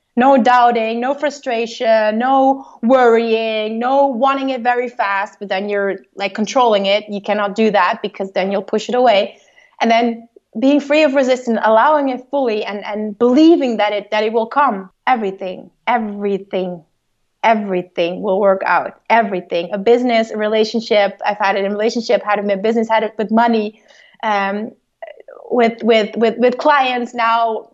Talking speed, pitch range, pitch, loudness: 170 wpm, 205-245 Hz, 225 Hz, -16 LUFS